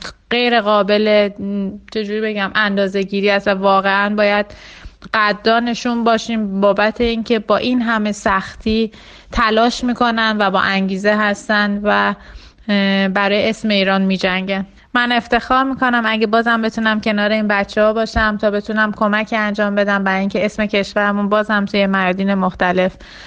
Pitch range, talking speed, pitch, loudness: 200-225 Hz, 135 wpm, 210 Hz, -16 LUFS